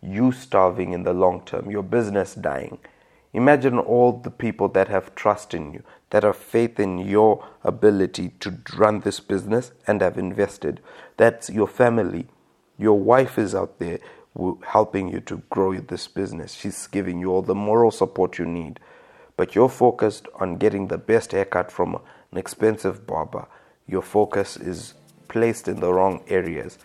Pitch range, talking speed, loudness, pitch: 95-120 Hz, 165 wpm, -22 LUFS, 105 Hz